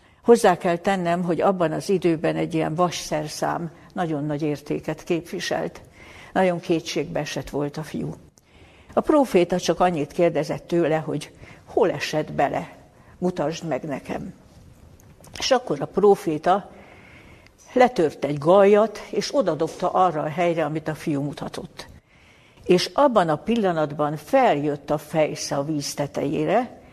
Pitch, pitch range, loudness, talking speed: 165 Hz, 150-185 Hz, -23 LUFS, 130 wpm